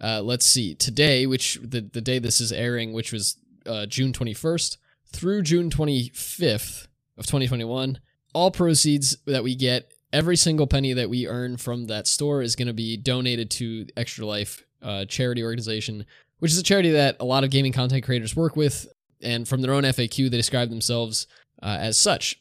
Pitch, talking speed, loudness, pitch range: 125 Hz, 185 wpm, -23 LUFS, 115-140 Hz